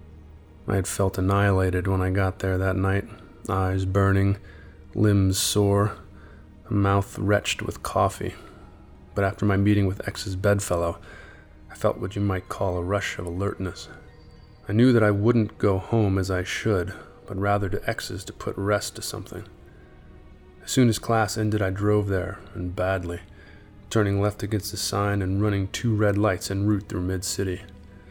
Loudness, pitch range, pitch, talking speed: -25 LUFS, 95-105 Hz, 100 Hz, 170 wpm